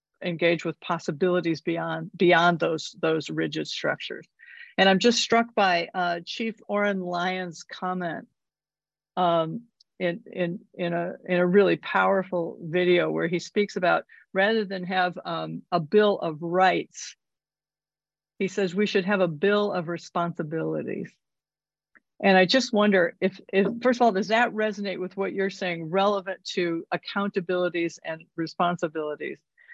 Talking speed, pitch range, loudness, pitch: 145 wpm, 170-195 Hz, -25 LUFS, 180 Hz